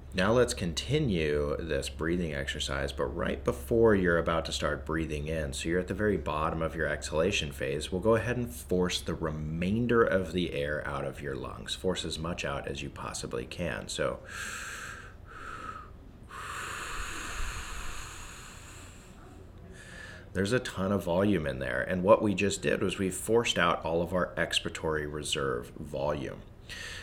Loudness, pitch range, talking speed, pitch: -31 LUFS, 75-95 Hz, 155 wpm, 85 Hz